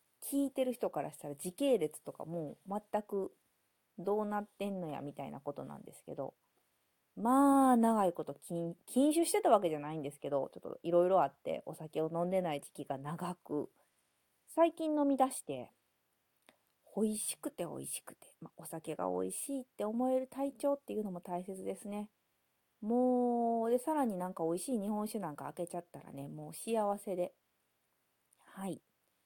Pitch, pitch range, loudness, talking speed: 200 Hz, 165-245 Hz, -36 LUFS, 335 characters per minute